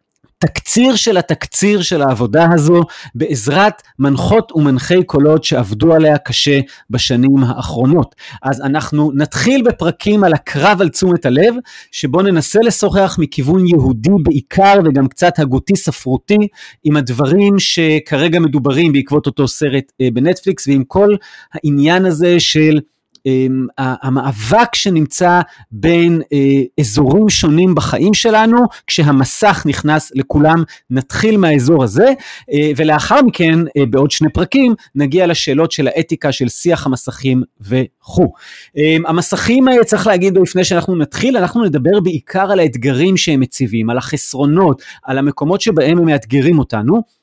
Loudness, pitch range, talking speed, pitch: -12 LUFS, 140-185 Hz, 120 wpm, 155 Hz